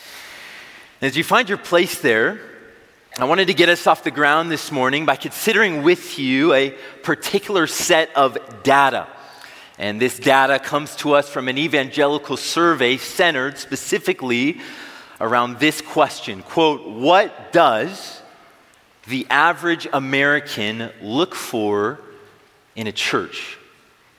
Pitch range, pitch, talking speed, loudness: 135-190 Hz, 150 Hz, 125 wpm, -18 LUFS